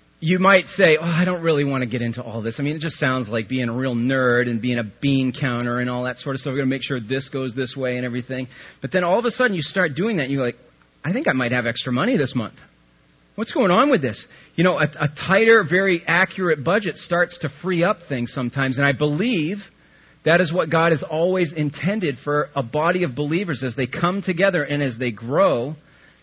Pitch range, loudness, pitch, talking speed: 125-175 Hz, -21 LUFS, 145 Hz, 250 wpm